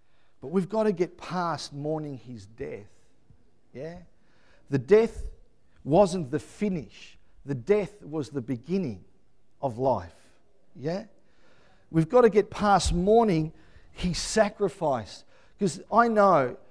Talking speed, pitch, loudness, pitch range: 120 wpm, 170 Hz, -26 LUFS, 140-205 Hz